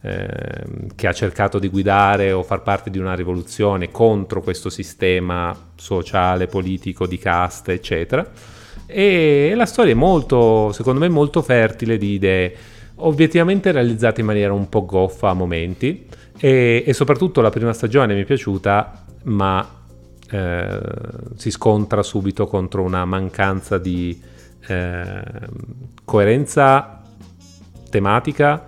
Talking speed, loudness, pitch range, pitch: 130 wpm, -18 LUFS, 95-120 Hz, 105 Hz